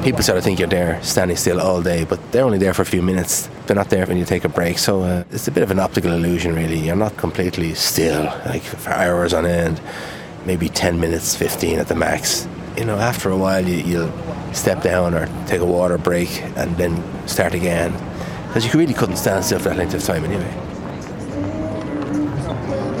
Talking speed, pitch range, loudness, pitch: 215 wpm, 85-100 Hz, -19 LUFS, 90 Hz